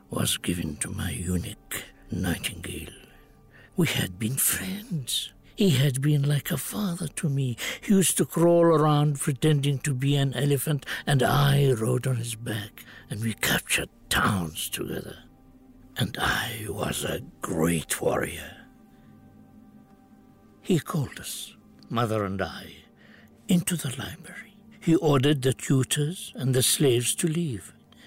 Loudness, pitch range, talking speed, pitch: -26 LUFS, 115-155 Hz, 135 wpm, 140 Hz